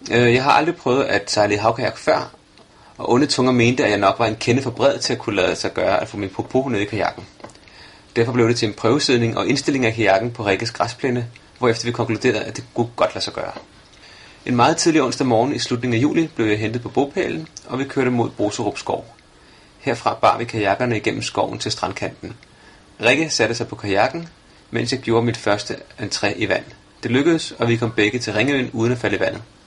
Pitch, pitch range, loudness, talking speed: 115 Hz, 110-125 Hz, -19 LUFS, 225 wpm